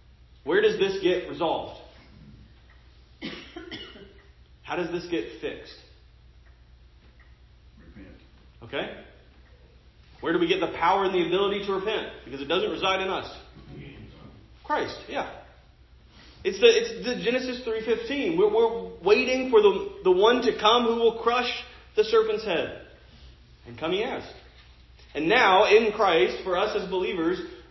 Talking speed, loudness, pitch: 135 wpm, -24 LUFS, 200 Hz